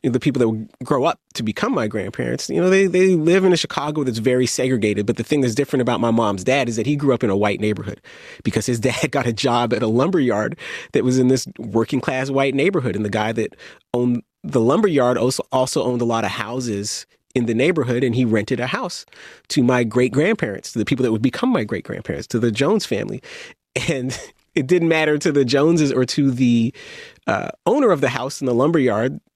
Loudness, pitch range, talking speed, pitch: -19 LUFS, 115-140 Hz, 240 wpm, 130 Hz